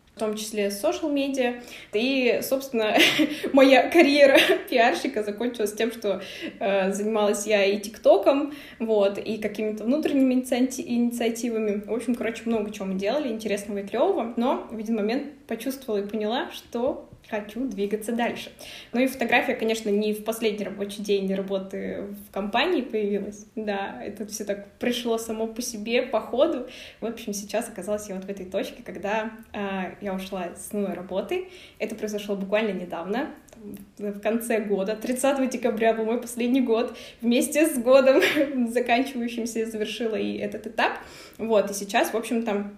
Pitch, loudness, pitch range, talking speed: 225 Hz, -25 LUFS, 205-250 Hz, 155 wpm